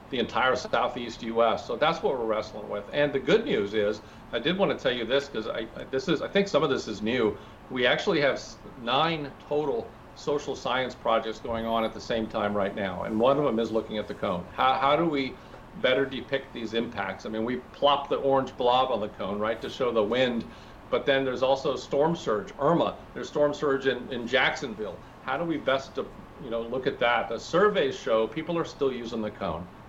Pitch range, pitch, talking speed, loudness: 110-135 Hz, 120 Hz, 225 wpm, -27 LUFS